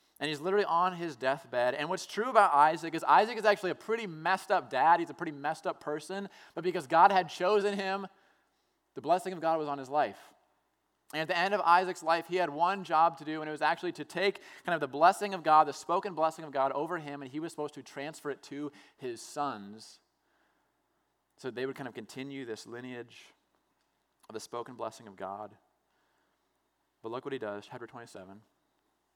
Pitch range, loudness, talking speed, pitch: 135-180 Hz, -30 LUFS, 210 wpm, 155 Hz